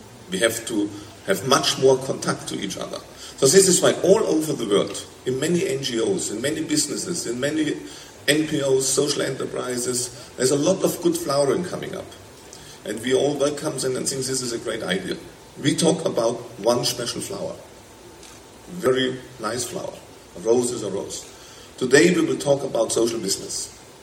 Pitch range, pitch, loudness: 120-155 Hz, 130 Hz, -22 LUFS